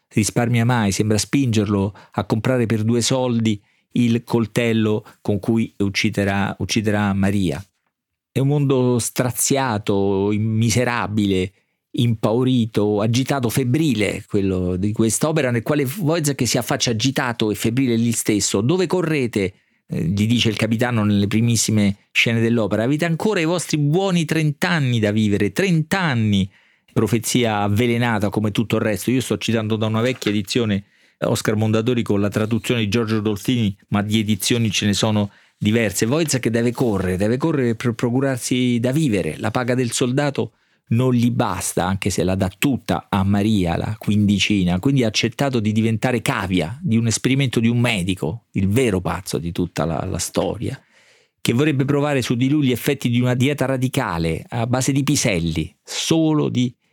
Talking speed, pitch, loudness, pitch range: 155 wpm, 115 Hz, -20 LUFS, 105-130 Hz